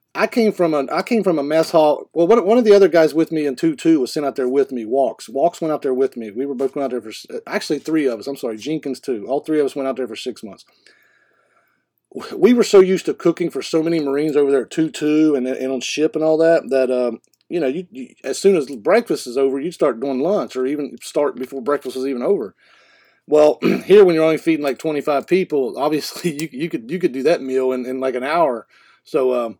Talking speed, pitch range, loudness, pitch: 265 wpm, 135-170 Hz, -18 LUFS, 150 Hz